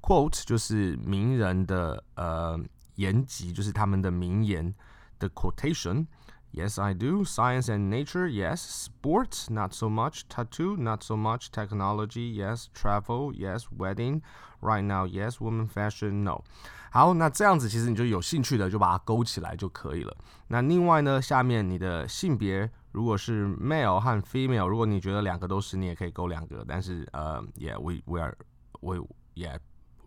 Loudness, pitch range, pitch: -29 LUFS, 95-120 Hz, 105 Hz